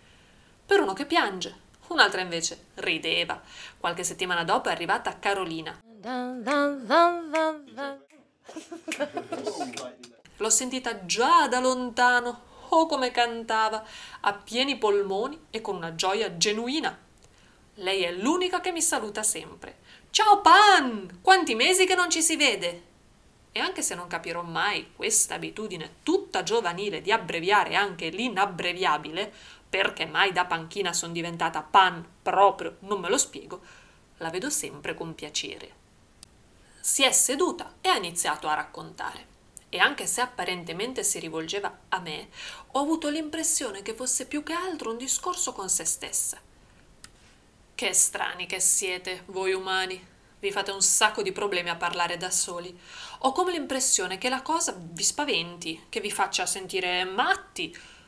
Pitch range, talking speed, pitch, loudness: 185-300 Hz, 140 wpm, 220 Hz, -25 LUFS